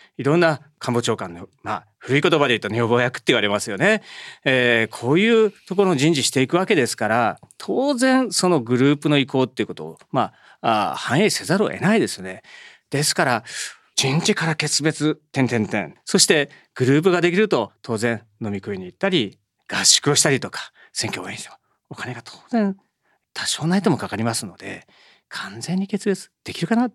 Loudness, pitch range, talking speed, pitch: -20 LUFS, 115-185 Hz, 360 characters per minute, 145 Hz